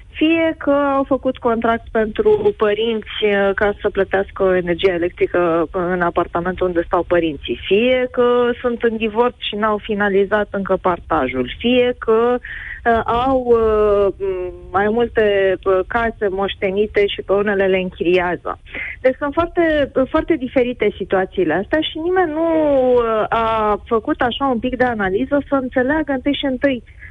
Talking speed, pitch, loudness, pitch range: 135 wpm, 225 Hz, -17 LUFS, 195-260 Hz